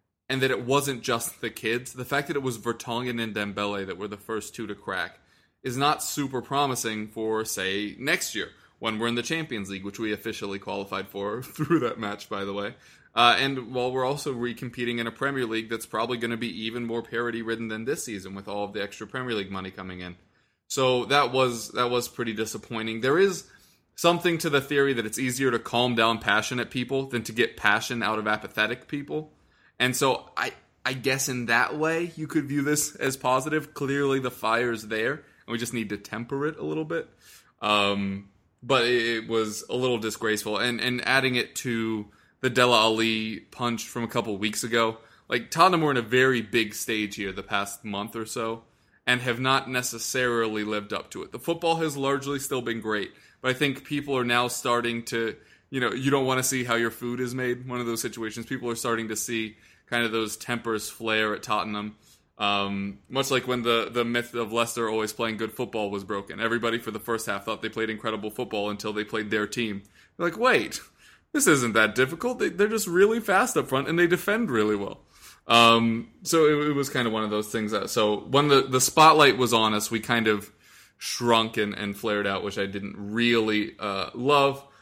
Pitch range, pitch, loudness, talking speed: 110-130 Hz, 115 Hz, -26 LUFS, 215 wpm